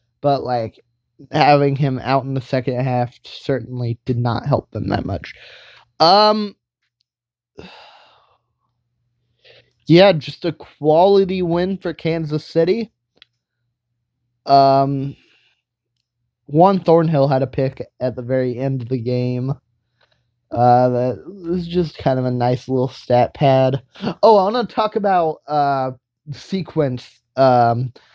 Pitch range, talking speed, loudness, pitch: 120-155 Hz, 125 wpm, -17 LUFS, 130 Hz